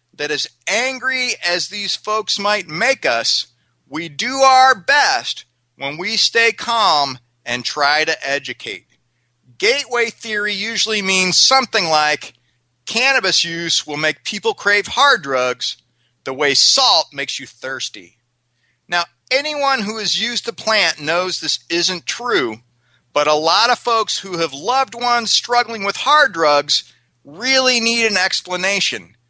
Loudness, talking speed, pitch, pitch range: -16 LUFS, 140 wpm, 180 Hz, 140-230 Hz